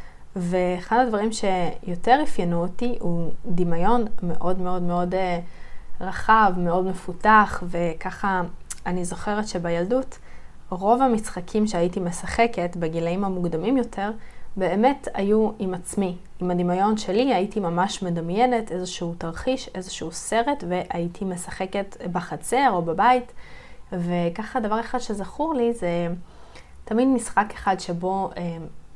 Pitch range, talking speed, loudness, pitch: 175-220 Hz, 110 wpm, -24 LUFS, 185 Hz